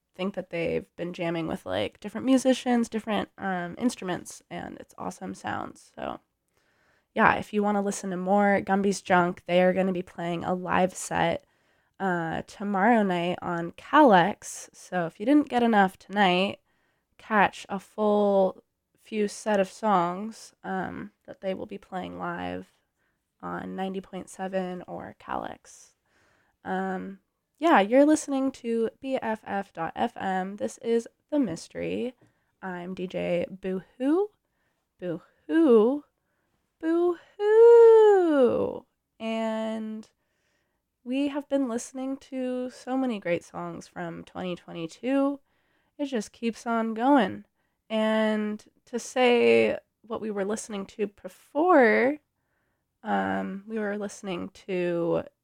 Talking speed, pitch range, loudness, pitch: 120 wpm, 180-245 Hz, -26 LUFS, 205 Hz